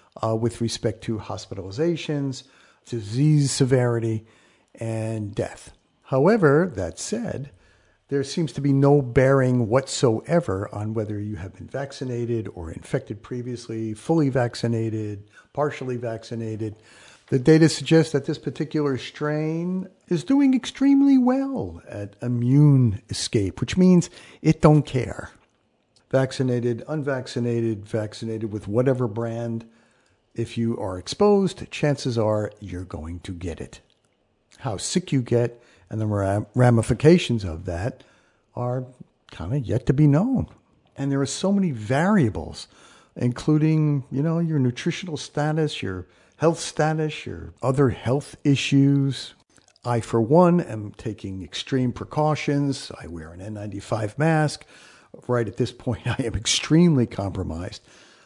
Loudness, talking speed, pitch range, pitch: -23 LUFS, 125 wpm, 110-150 Hz, 125 Hz